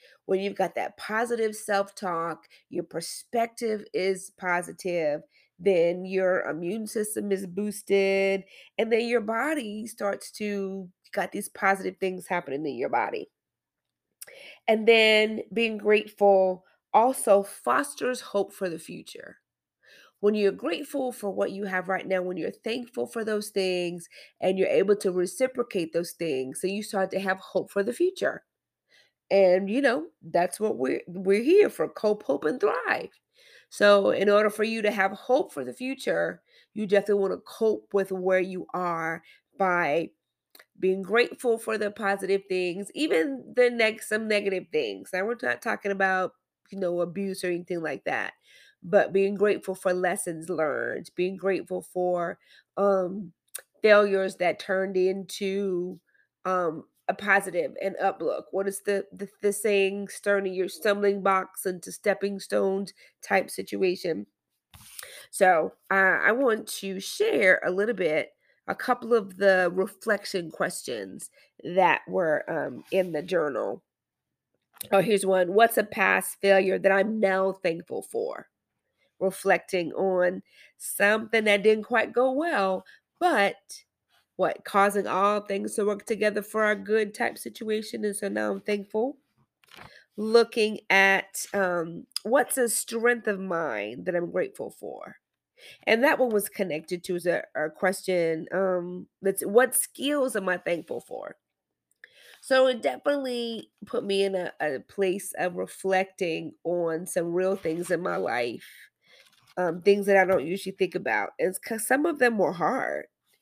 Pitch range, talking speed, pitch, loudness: 185-215 Hz, 150 wpm, 195 Hz, -26 LUFS